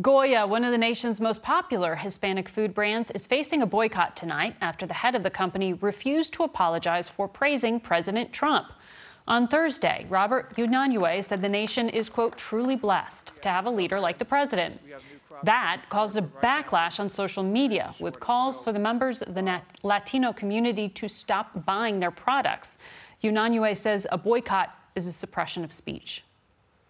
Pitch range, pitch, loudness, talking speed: 190-240 Hz, 215 Hz, -26 LUFS, 170 wpm